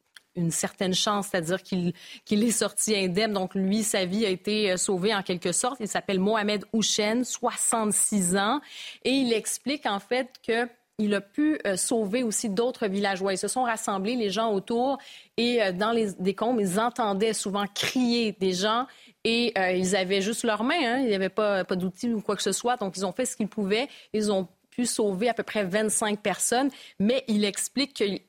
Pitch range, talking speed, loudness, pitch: 195-235 Hz, 200 wpm, -26 LUFS, 215 Hz